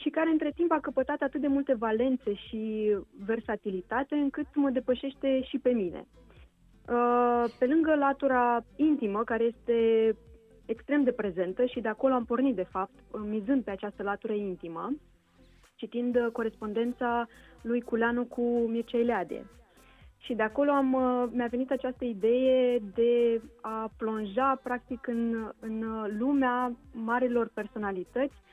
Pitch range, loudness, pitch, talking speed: 220-260 Hz, -29 LUFS, 240 Hz, 135 wpm